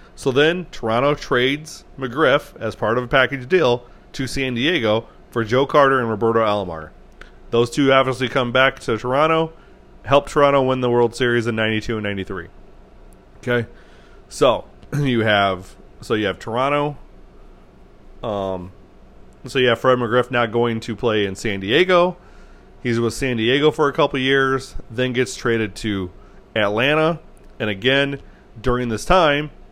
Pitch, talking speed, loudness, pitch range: 120 Hz, 155 wpm, -19 LUFS, 110-135 Hz